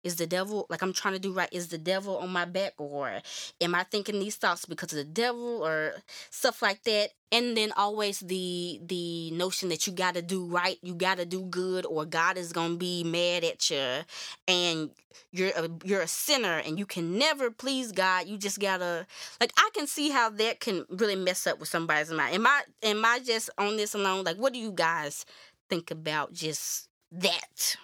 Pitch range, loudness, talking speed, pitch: 175-210 Hz, -29 LUFS, 210 wpm, 185 Hz